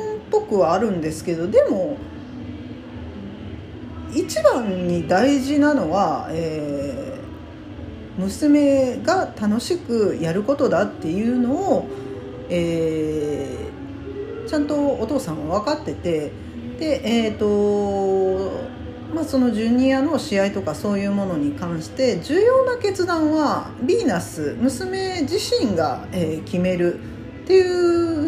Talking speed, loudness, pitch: 215 characters per minute, -21 LUFS, 235 Hz